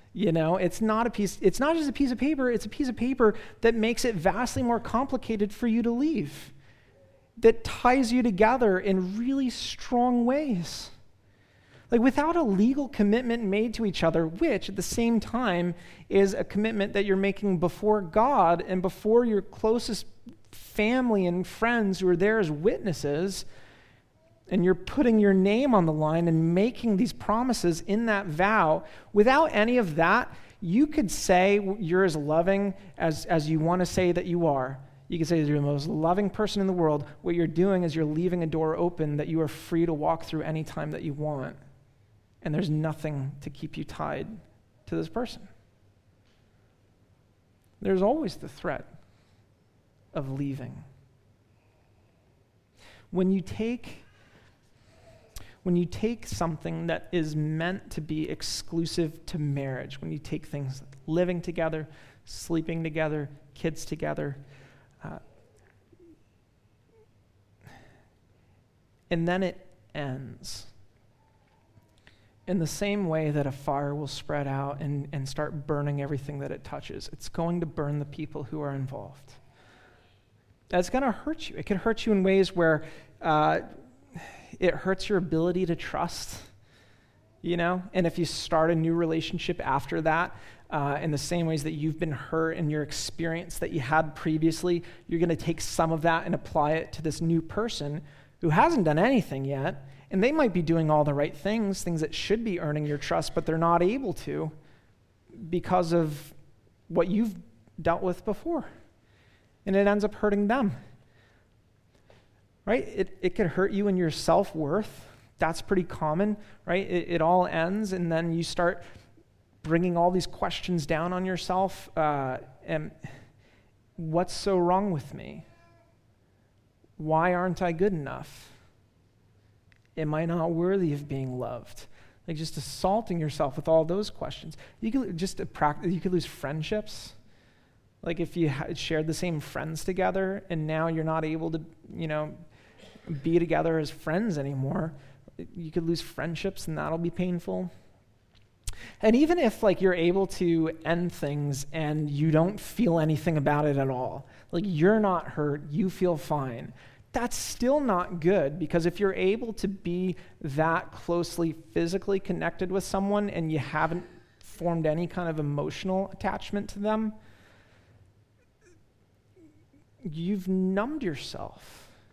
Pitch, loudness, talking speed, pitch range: 165 Hz, -28 LUFS, 160 wpm, 135-190 Hz